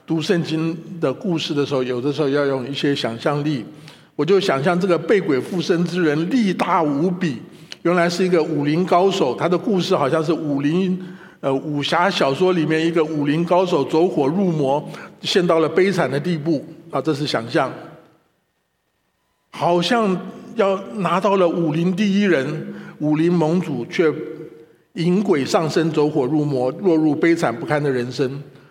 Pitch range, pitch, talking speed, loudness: 150-180 Hz, 165 Hz, 245 characters per minute, -19 LUFS